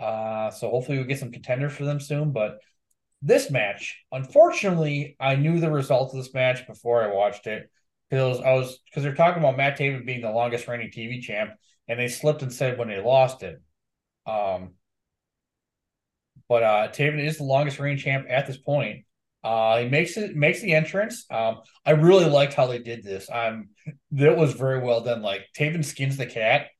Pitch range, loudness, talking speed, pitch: 120-145 Hz, -24 LUFS, 195 wpm, 135 Hz